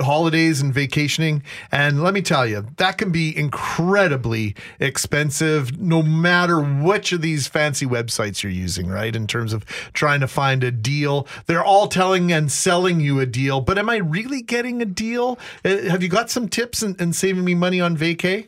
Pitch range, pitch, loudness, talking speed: 140-185 Hz, 160 Hz, -19 LUFS, 185 wpm